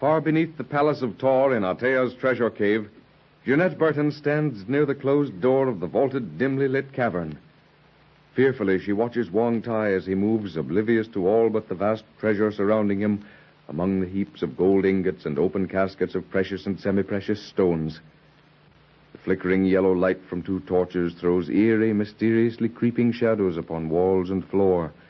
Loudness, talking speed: -24 LUFS, 170 wpm